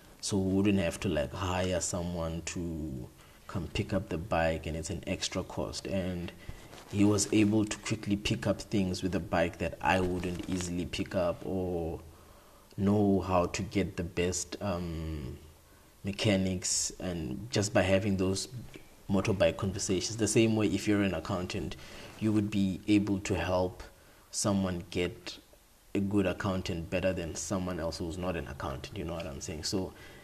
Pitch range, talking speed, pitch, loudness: 85-100 Hz, 170 wpm, 95 Hz, -32 LUFS